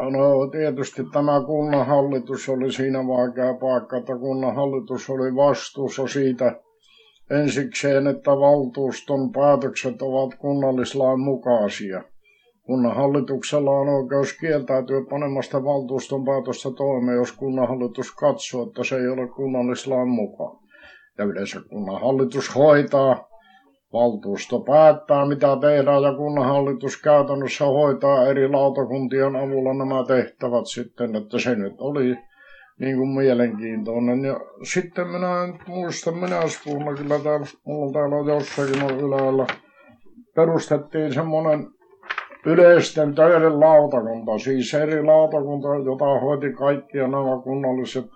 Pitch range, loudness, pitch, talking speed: 130-145 Hz, -21 LUFS, 135 Hz, 110 wpm